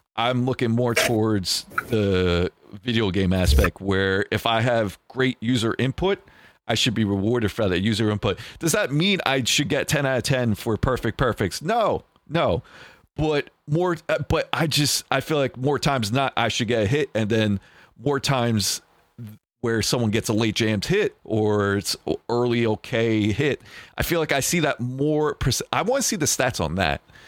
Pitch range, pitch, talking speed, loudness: 110-140 Hz, 120 Hz, 185 wpm, -23 LUFS